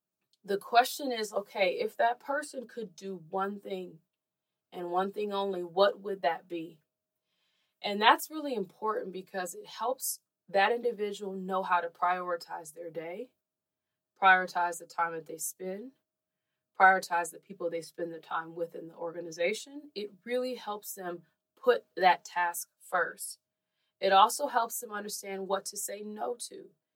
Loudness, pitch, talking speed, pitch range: -31 LUFS, 195 Hz, 155 wpm, 175-215 Hz